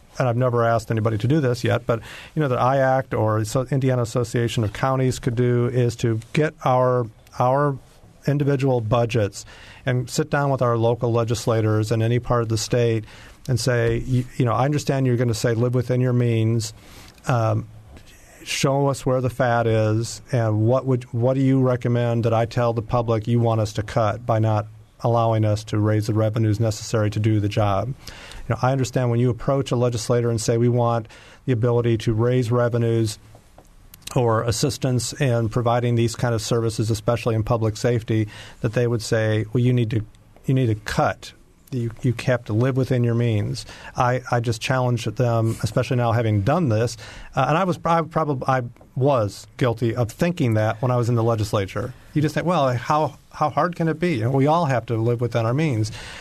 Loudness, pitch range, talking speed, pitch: -22 LUFS, 110-130 Hz, 205 wpm, 120 Hz